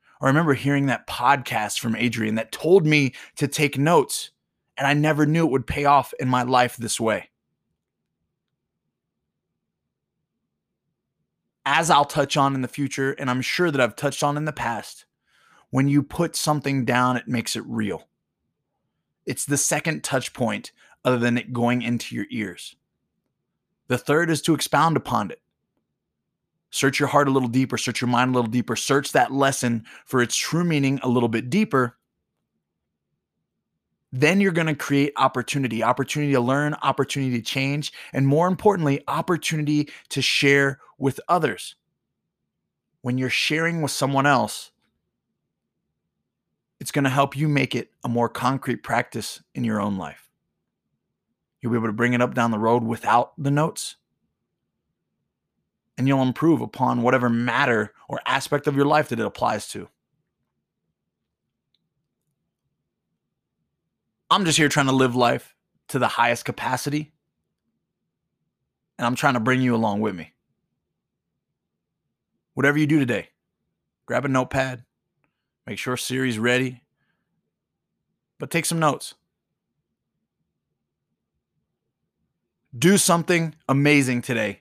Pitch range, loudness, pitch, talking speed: 120-145 Hz, -22 LUFS, 135 Hz, 145 wpm